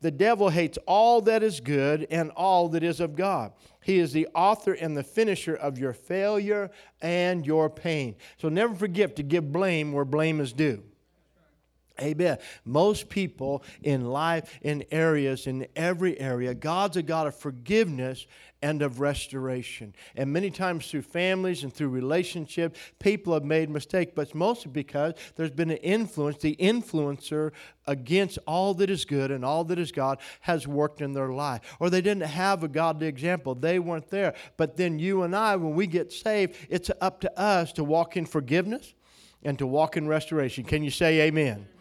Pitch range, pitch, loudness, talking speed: 145-185 Hz, 160 Hz, -27 LUFS, 180 wpm